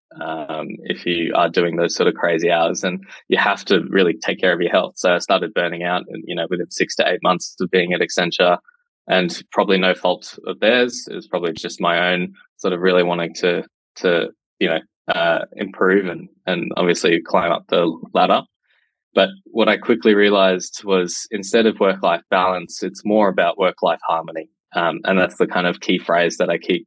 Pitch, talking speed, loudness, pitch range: 95 Hz, 205 wpm, -19 LUFS, 85-105 Hz